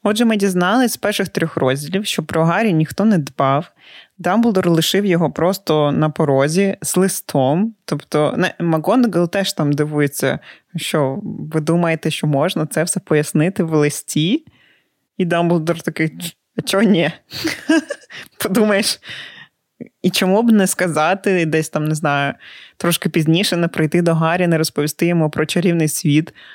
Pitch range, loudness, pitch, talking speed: 155-195 Hz, -17 LUFS, 170 Hz, 145 wpm